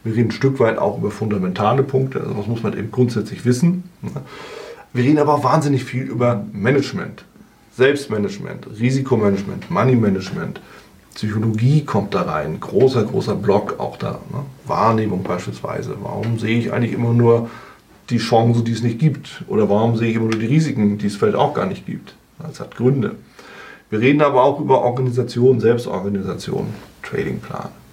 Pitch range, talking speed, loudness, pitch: 110-135 Hz, 165 wpm, -18 LUFS, 120 Hz